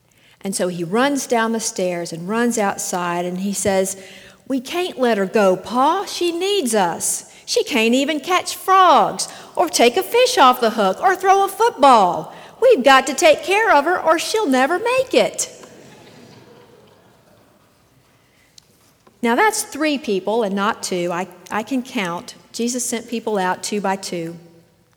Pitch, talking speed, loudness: 235 Hz, 165 wpm, -18 LUFS